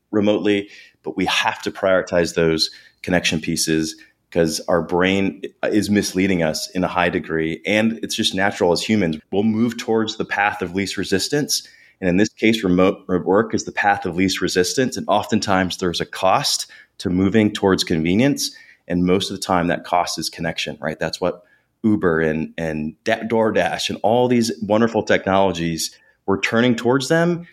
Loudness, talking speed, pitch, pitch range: -19 LUFS, 170 wpm, 95 Hz, 85-110 Hz